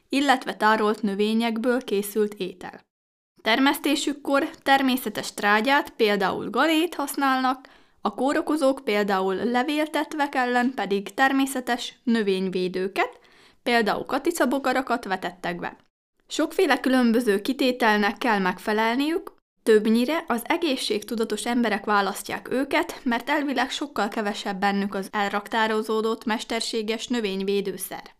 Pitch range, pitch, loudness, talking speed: 210-275 Hz, 235 Hz, -24 LUFS, 90 wpm